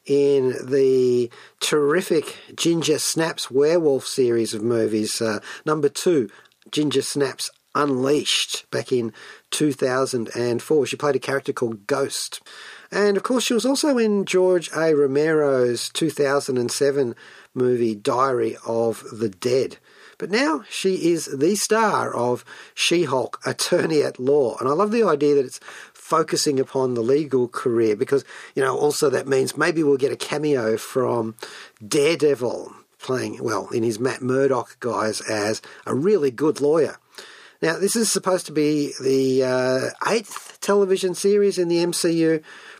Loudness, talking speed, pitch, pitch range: -21 LUFS, 145 wpm, 145 Hz, 130-195 Hz